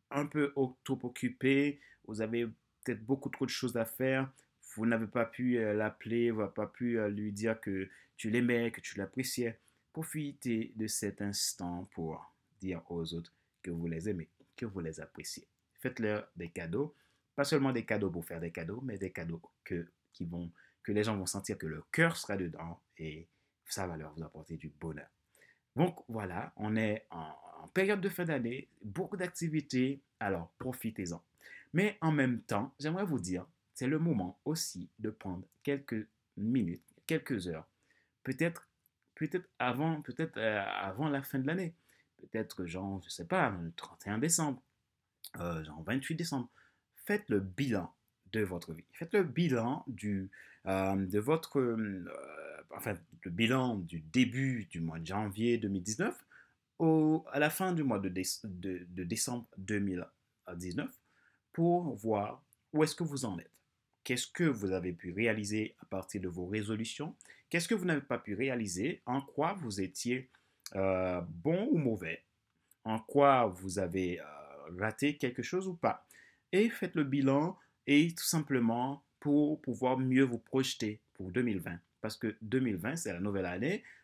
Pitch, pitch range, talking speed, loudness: 115 Hz, 95-140 Hz, 165 wpm, -35 LUFS